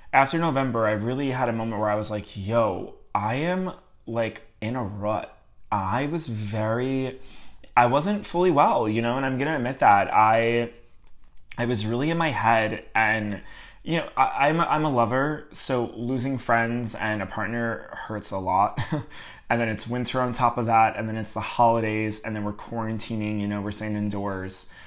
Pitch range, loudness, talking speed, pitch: 110-130 Hz, -25 LUFS, 190 wpm, 115 Hz